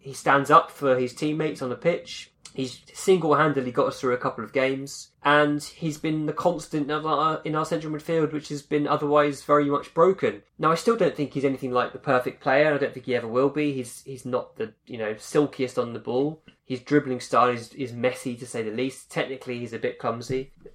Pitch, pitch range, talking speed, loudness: 135 Hz, 125-150 Hz, 230 wpm, -25 LUFS